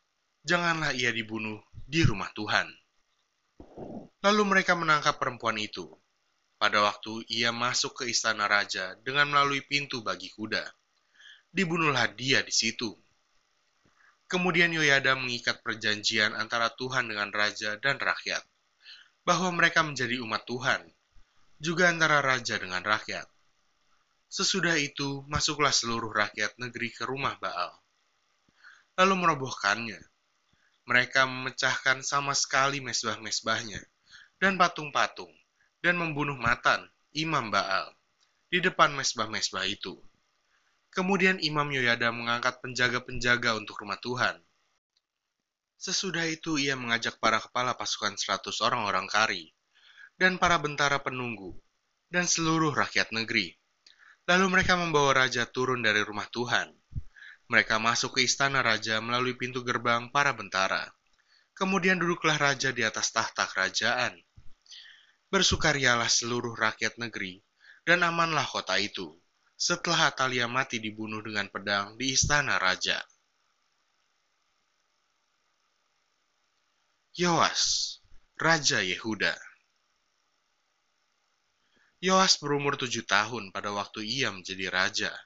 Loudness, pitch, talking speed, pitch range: -27 LUFS, 130 Hz, 110 wpm, 110-150 Hz